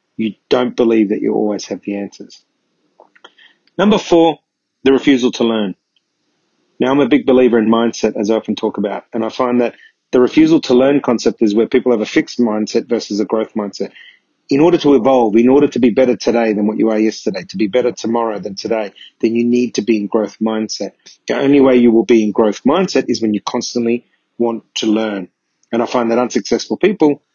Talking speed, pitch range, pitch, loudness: 215 wpm, 110-130 Hz, 115 Hz, -15 LUFS